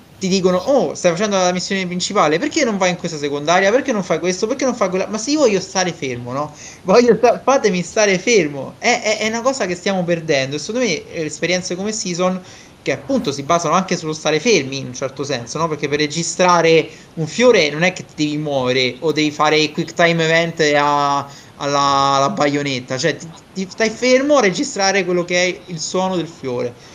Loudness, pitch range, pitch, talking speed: -17 LUFS, 150-195 Hz, 175 Hz, 220 wpm